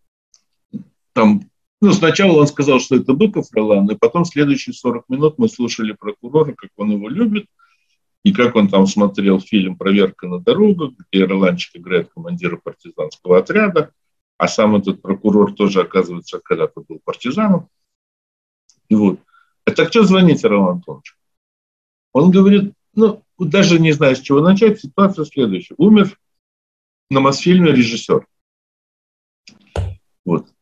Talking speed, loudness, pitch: 135 wpm, -15 LUFS, 140 Hz